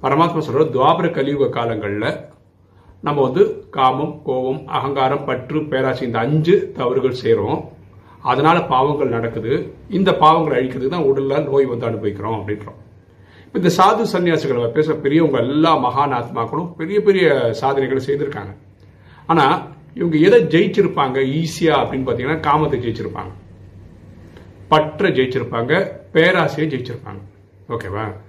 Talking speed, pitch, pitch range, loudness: 110 wpm, 135 Hz, 110-155 Hz, -17 LUFS